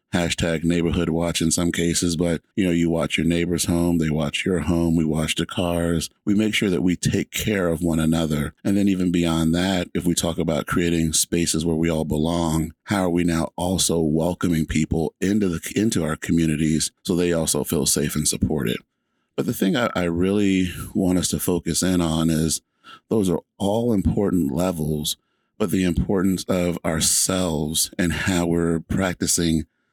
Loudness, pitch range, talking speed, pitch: -22 LUFS, 80-90 Hz, 185 wpm, 85 Hz